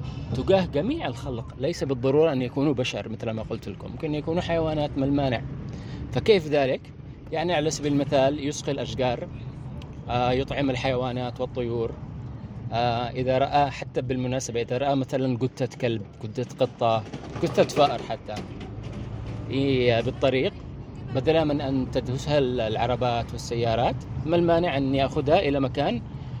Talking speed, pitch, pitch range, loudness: 130 wpm, 130 Hz, 120-140 Hz, -26 LUFS